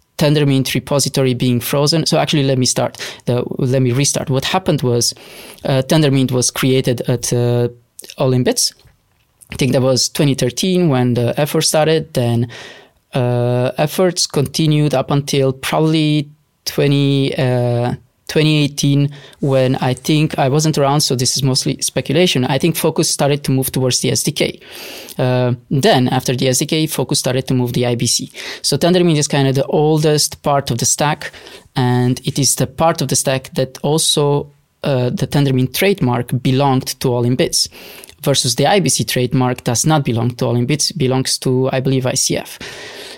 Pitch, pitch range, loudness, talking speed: 135 Hz, 130-150 Hz, -15 LUFS, 165 wpm